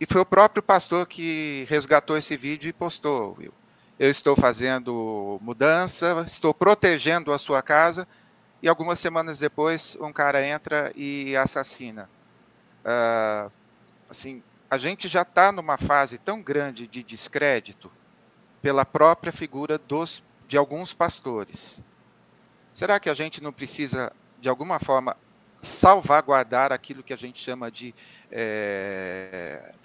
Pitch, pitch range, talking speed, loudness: 145 Hz, 130-165 Hz, 130 wpm, -23 LUFS